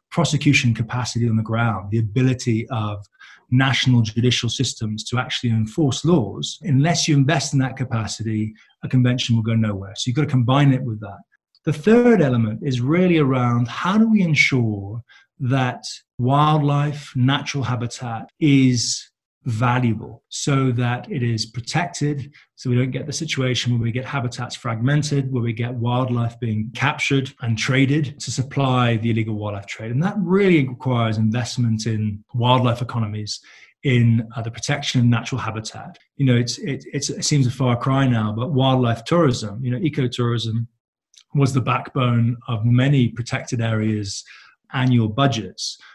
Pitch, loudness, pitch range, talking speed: 125 Hz, -20 LUFS, 115-140 Hz, 160 wpm